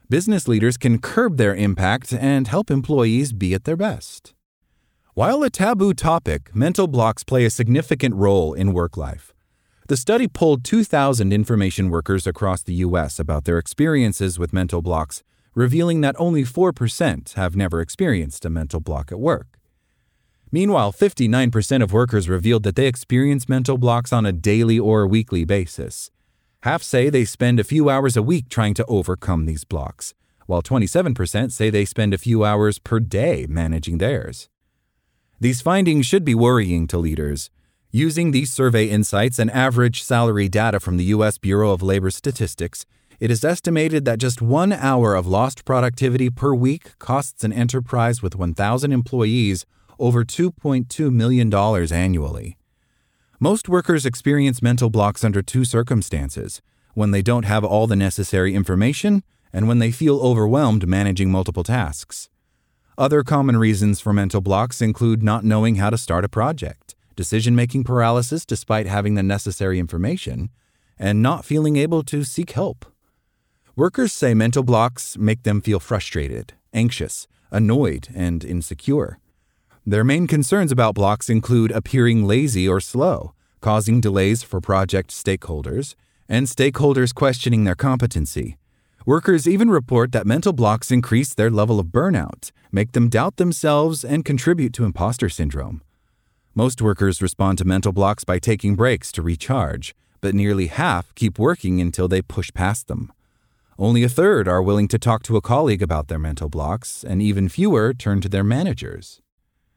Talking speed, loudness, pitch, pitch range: 155 wpm, -19 LUFS, 110 Hz, 95-130 Hz